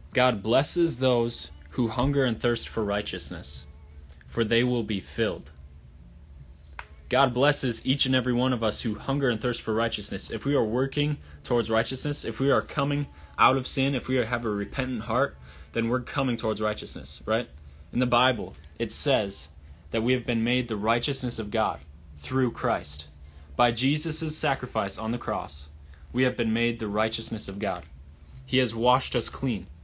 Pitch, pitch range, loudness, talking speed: 115 Hz, 80-130 Hz, -27 LUFS, 175 wpm